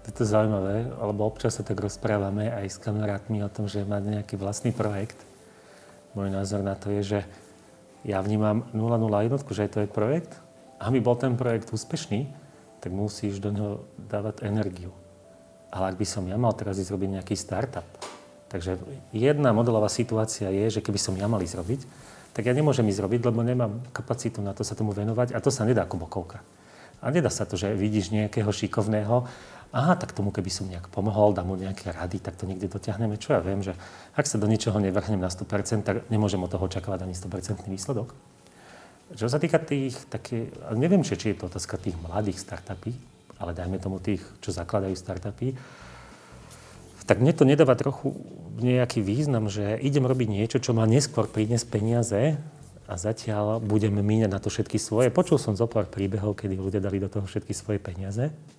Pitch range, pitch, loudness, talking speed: 100-120 Hz, 105 Hz, -27 LUFS, 190 wpm